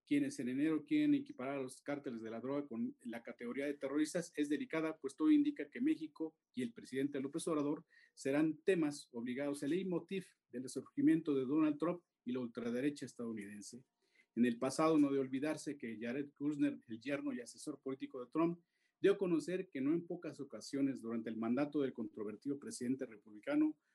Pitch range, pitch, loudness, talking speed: 130-165 Hz, 145 Hz, -39 LUFS, 185 wpm